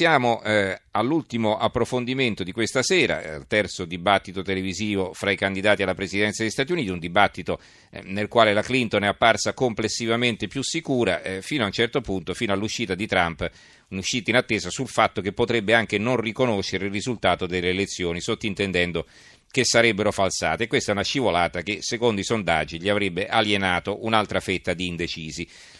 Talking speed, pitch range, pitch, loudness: 165 wpm, 95-115 Hz, 105 Hz, -23 LUFS